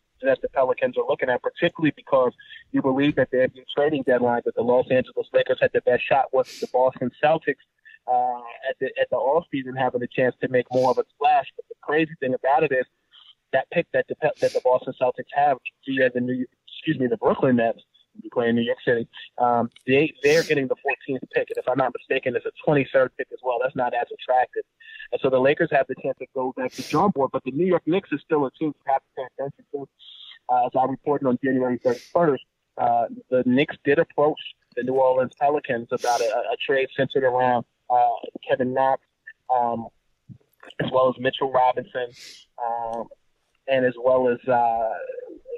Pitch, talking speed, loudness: 135 Hz, 205 wpm, -23 LUFS